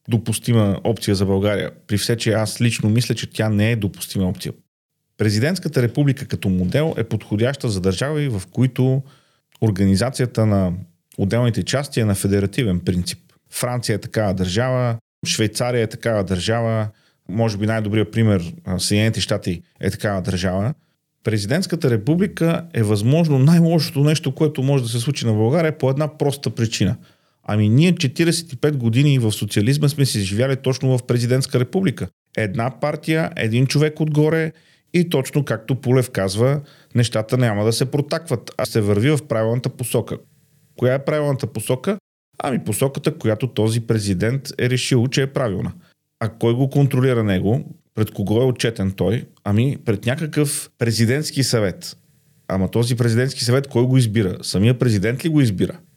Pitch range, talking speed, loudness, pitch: 110-140 Hz, 155 wpm, -20 LUFS, 120 Hz